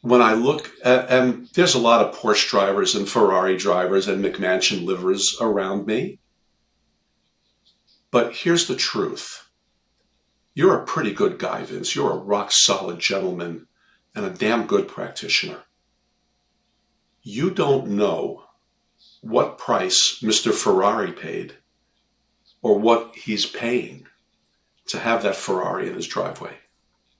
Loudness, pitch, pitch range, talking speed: -20 LUFS, 105 Hz, 95-120 Hz, 130 wpm